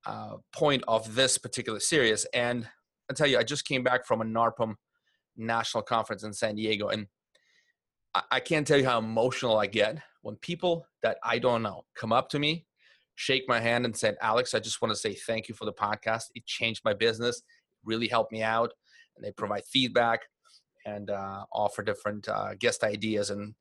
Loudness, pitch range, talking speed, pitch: -29 LUFS, 110-130 Hz, 200 wpm, 115 Hz